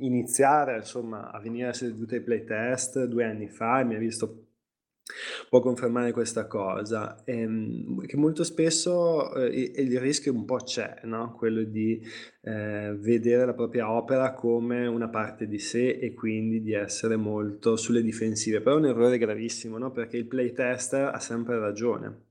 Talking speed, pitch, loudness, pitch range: 165 wpm, 115 Hz, -28 LUFS, 110-125 Hz